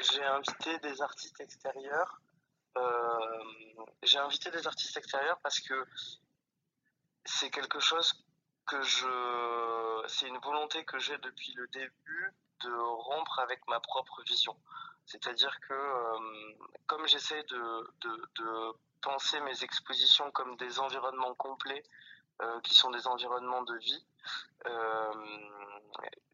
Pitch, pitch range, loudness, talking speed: 130 Hz, 115-145 Hz, -33 LUFS, 130 wpm